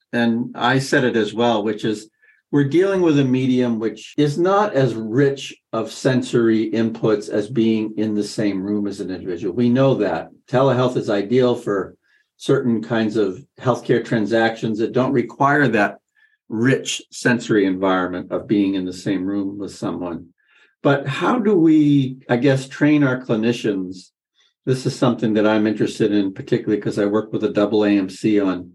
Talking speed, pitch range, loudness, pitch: 170 wpm, 105-135 Hz, -19 LUFS, 115 Hz